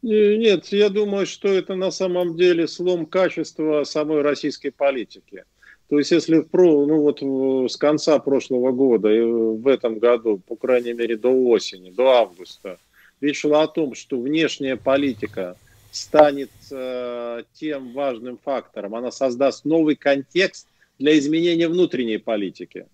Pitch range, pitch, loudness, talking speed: 125-165 Hz, 140 Hz, -20 LUFS, 140 wpm